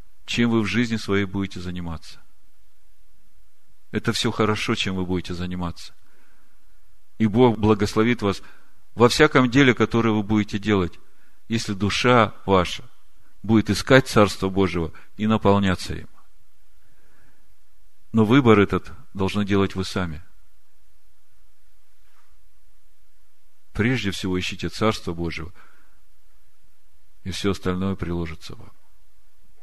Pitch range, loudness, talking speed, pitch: 85-110 Hz, -22 LUFS, 105 wpm, 100 Hz